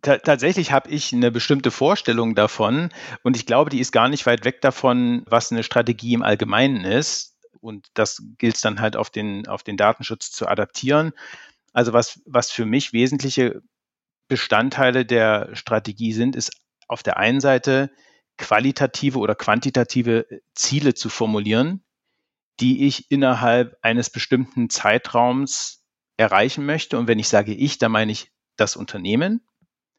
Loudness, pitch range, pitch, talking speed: -20 LUFS, 115-135 Hz, 125 Hz, 150 wpm